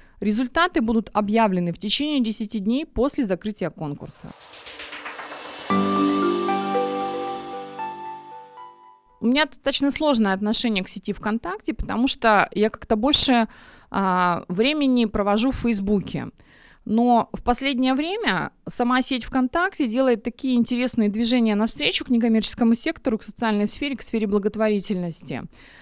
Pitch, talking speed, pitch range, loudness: 225 Hz, 115 wpm, 200-255 Hz, -21 LUFS